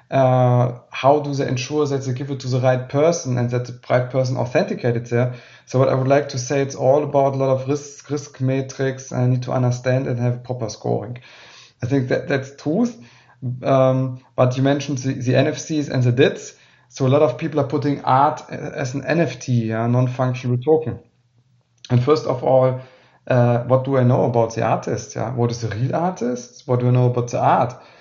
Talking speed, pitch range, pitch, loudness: 210 wpm, 125-140 Hz, 130 Hz, -20 LUFS